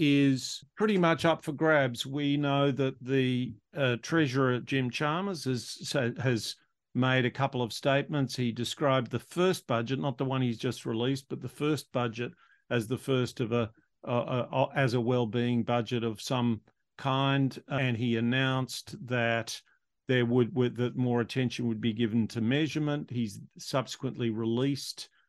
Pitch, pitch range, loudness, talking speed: 130 Hz, 120-140 Hz, -30 LUFS, 160 wpm